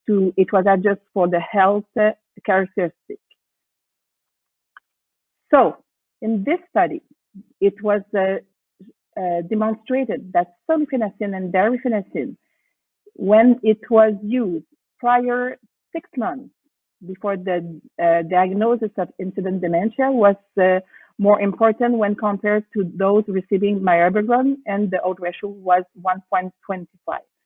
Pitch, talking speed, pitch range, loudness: 205 Hz, 115 wpm, 190-235 Hz, -20 LUFS